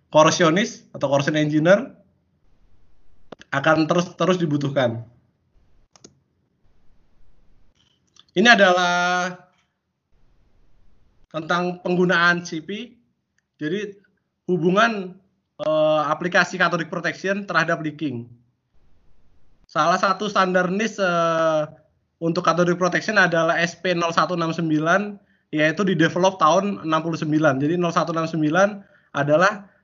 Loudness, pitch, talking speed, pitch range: -20 LUFS, 170 Hz, 75 wpm, 155-185 Hz